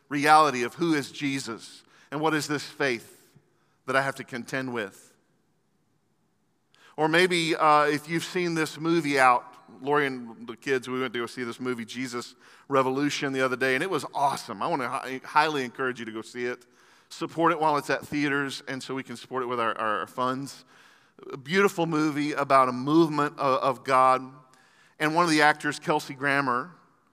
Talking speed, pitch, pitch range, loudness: 195 wpm, 140 Hz, 130-150 Hz, -26 LUFS